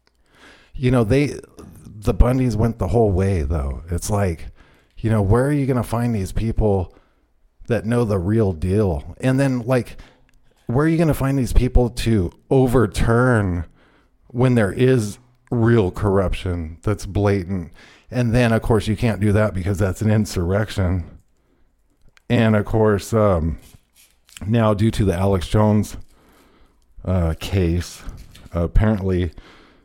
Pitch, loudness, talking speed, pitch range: 105 Hz, -20 LUFS, 145 wpm, 90-115 Hz